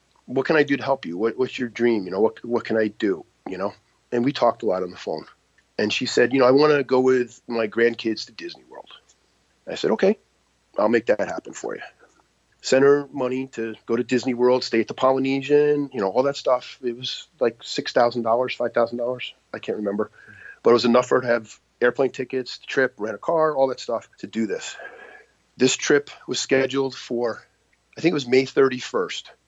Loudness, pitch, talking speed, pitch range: -22 LUFS, 125 Hz, 230 wpm, 120-135 Hz